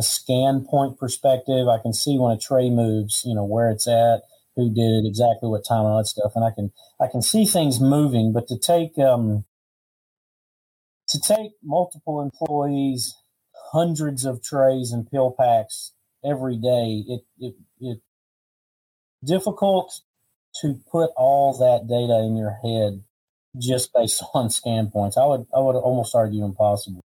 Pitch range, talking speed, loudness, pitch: 110-140 Hz, 160 wpm, -21 LUFS, 125 Hz